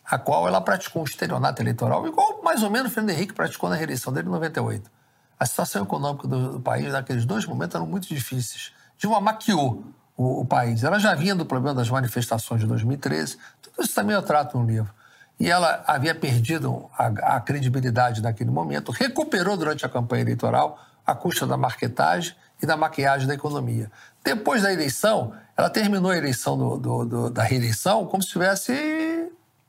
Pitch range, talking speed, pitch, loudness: 120-190 Hz, 185 wpm, 135 Hz, -24 LUFS